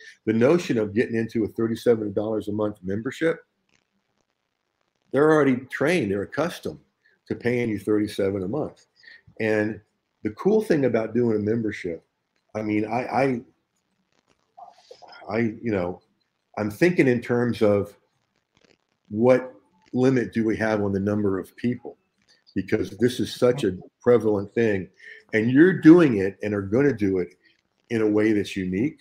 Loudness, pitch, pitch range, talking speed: -23 LUFS, 110 Hz, 105-125 Hz, 150 wpm